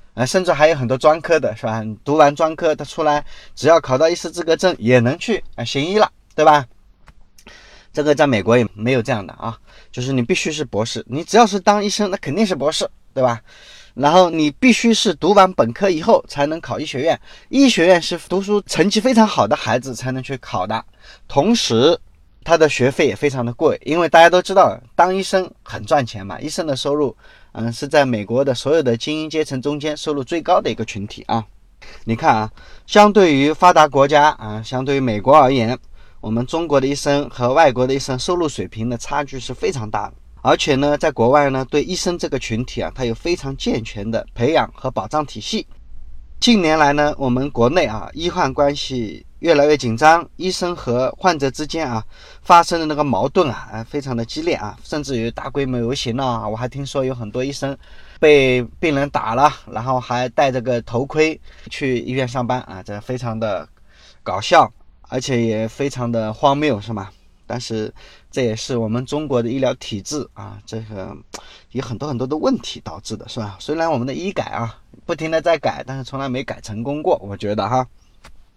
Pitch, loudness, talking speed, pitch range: 135 Hz, -18 LUFS, 295 characters per minute, 115-155 Hz